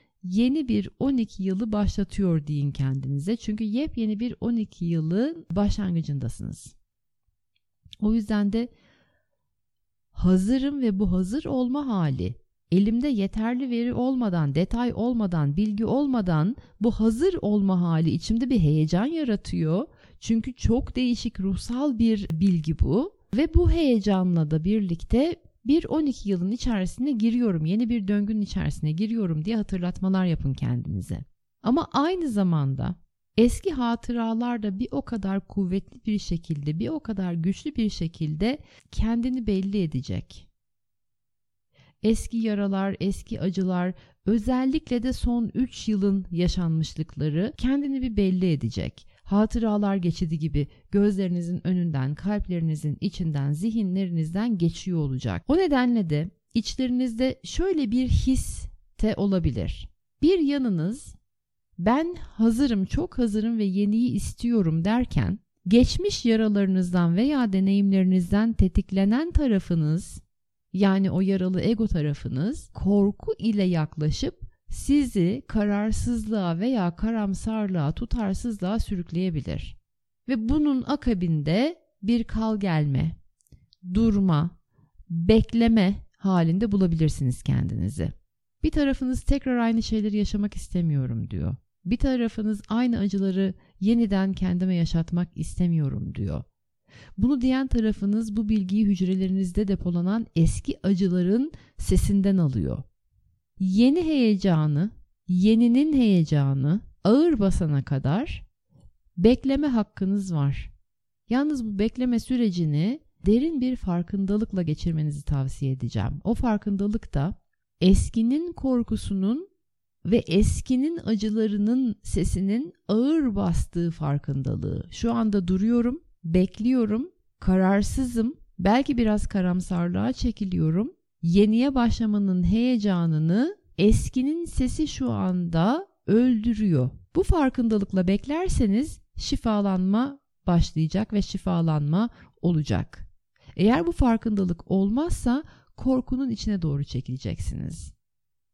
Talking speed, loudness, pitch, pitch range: 100 wpm, -25 LUFS, 200 Hz, 170-235 Hz